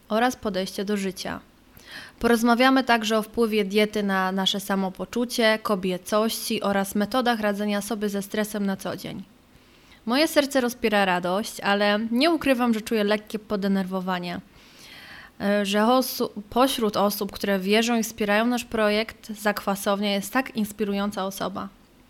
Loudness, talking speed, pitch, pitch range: -24 LUFS, 130 wpm, 210 Hz, 200-235 Hz